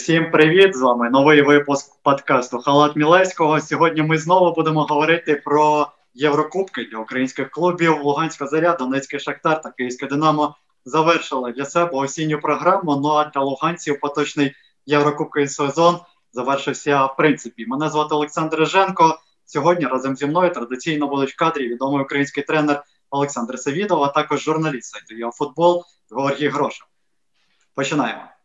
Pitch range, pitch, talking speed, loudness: 140-160 Hz, 150 Hz, 140 wpm, -19 LUFS